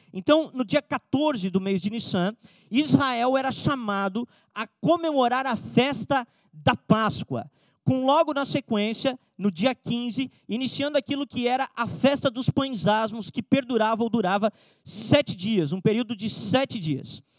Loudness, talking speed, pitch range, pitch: -25 LUFS, 150 wpm, 200-265 Hz, 235 Hz